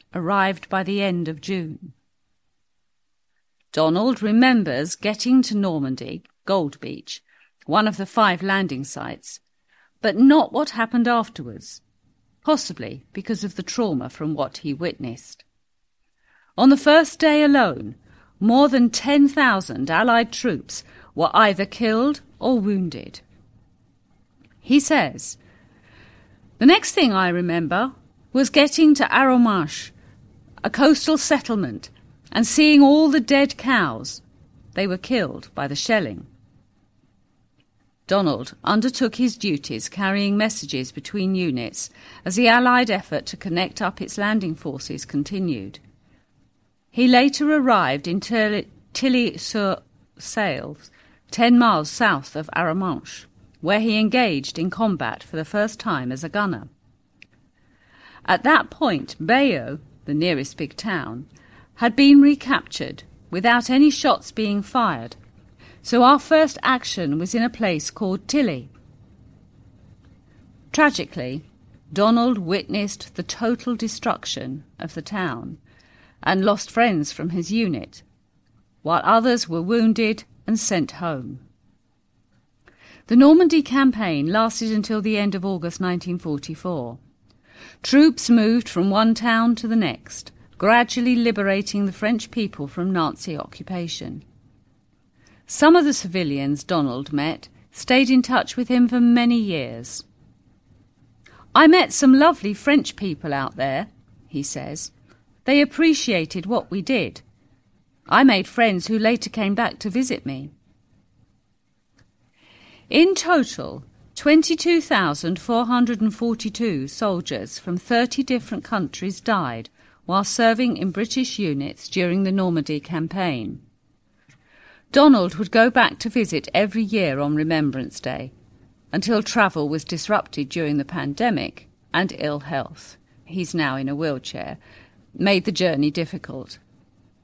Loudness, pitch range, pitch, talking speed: -20 LUFS, 140-235 Hz, 190 Hz, 120 wpm